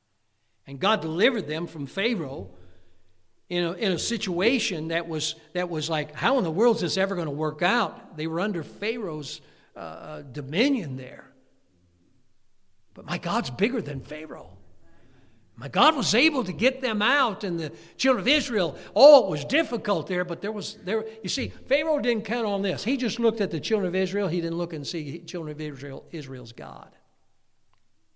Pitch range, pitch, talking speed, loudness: 135-220 Hz, 170 Hz, 185 wpm, -25 LUFS